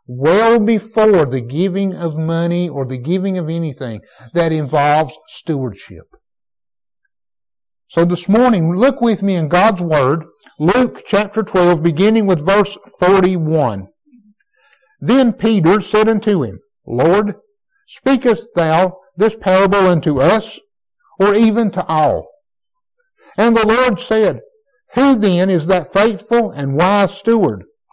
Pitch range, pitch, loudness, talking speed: 170-225 Hz, 195 Hz, -14 LUFS, 125 wpm